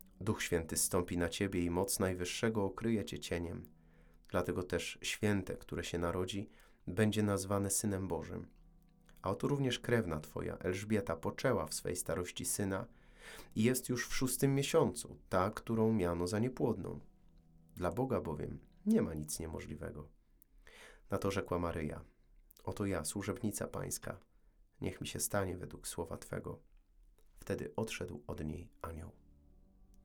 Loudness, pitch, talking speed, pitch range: -37 LUFS, 95 Hz, 140 wpm, 85-110 Hz